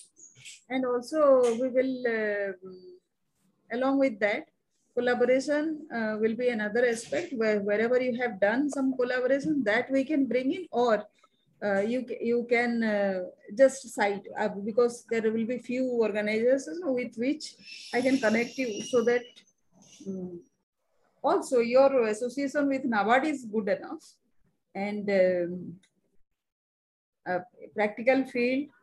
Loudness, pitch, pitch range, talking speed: -28 LUFS, 240 Hz, 210-260 Hz, 130 wpm